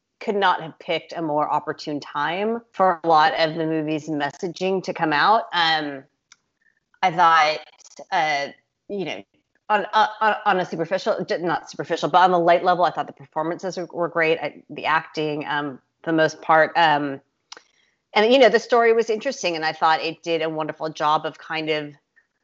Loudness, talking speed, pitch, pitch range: -21 LUFS, 185 wpm, 165 Hz, 155-185 Hz